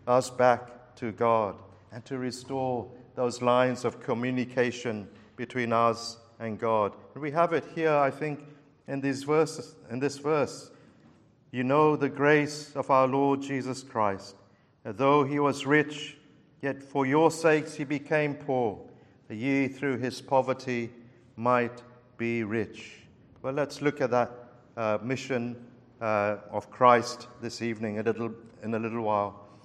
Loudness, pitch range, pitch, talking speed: -28 LUFS, 115-140 Hz, 125 Hz, 150 wpm